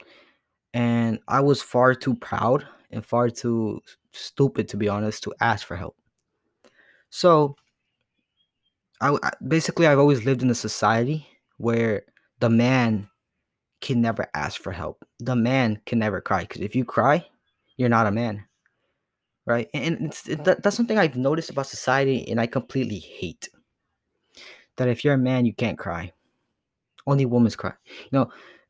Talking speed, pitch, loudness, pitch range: 160 wpm, 120 Hz, -23 LUFS, 115-135 Hz